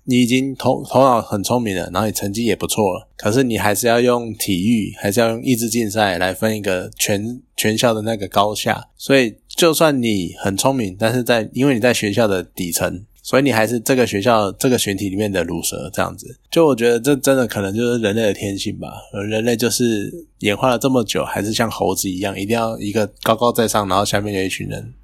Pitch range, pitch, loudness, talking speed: 100-125 Hz, 110 Hz, -18 LUFS, 335 characters per minute